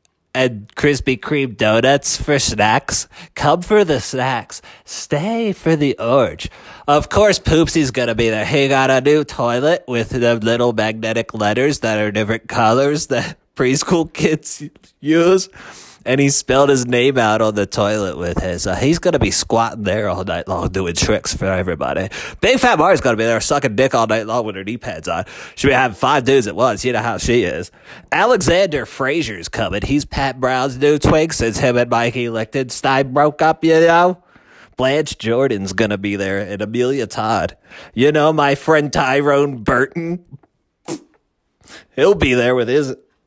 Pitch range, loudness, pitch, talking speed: 110-145 Hz, -16 LUFS, 130 Hz, 180 wpm